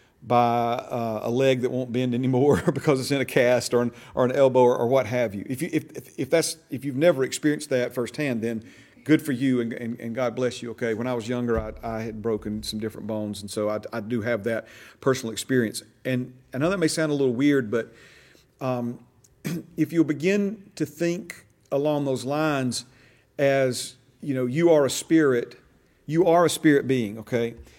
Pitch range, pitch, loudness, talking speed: 120-145 Hz, 125 Hz, -24 LUFS, 210 wpm